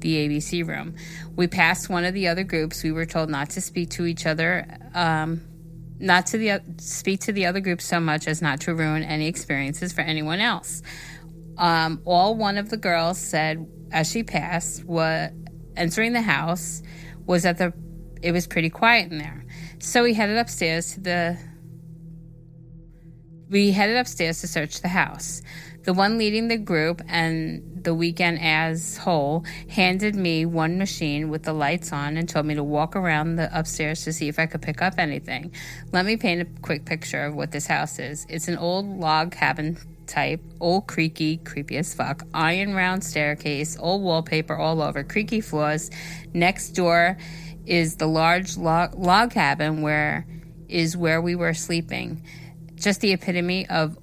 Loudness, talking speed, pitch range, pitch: -23 LUFS, 175 wpm, 155-175 Hz, 165 Hz